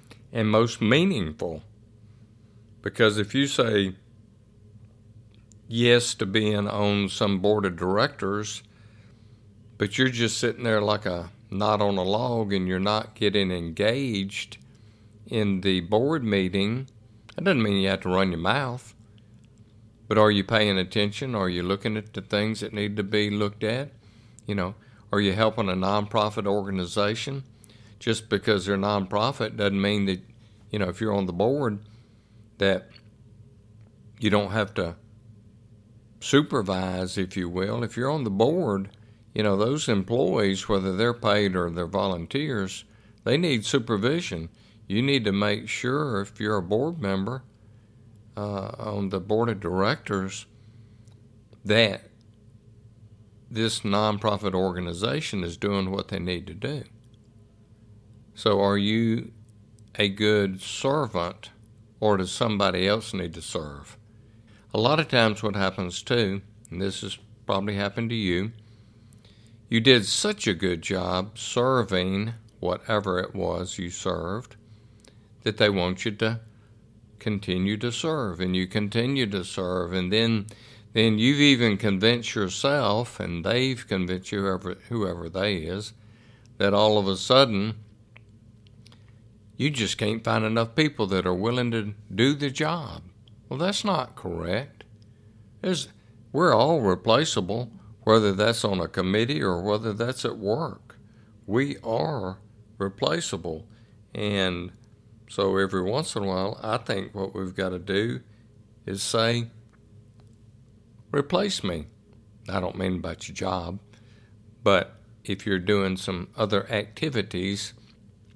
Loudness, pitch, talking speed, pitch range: -25 LUFS, 105 Hz, 140 wpm, 100-115 Hz